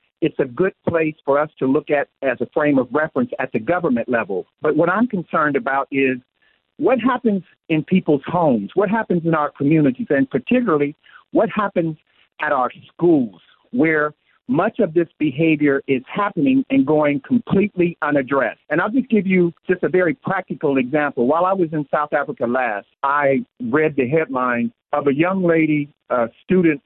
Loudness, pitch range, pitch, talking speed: -19 LUFS, 145-190 Hz, 160 Hz, 175 wpm